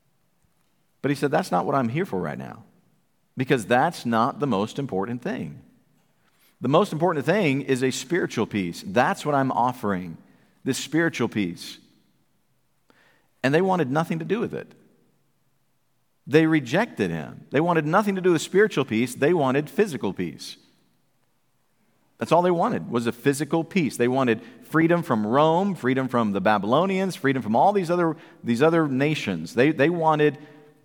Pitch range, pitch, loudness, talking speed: 125-170 Hz, 150 Hz, -23 LUFS, 165 wpm